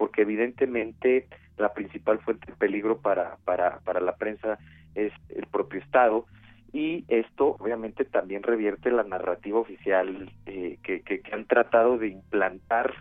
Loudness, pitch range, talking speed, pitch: -27 LUFS, 100-115 Hz, 150 wpm, 110 Hz